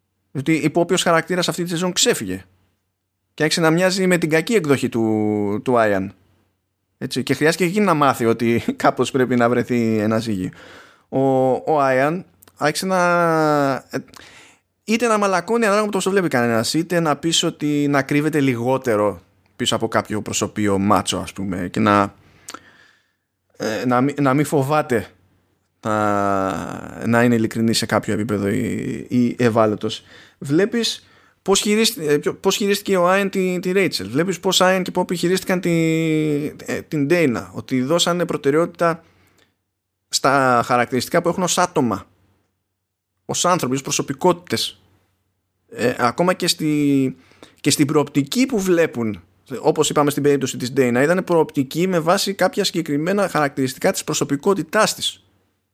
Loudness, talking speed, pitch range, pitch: -19 LUFS, 140 wpm, 105-170 Hz, 140 Hz